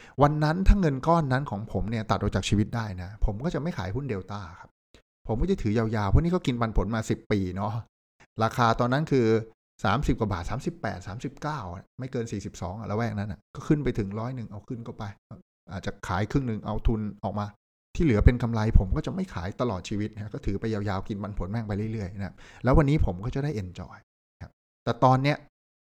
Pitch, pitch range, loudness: 110 Hz, 100-130 Hz, -28 LUFS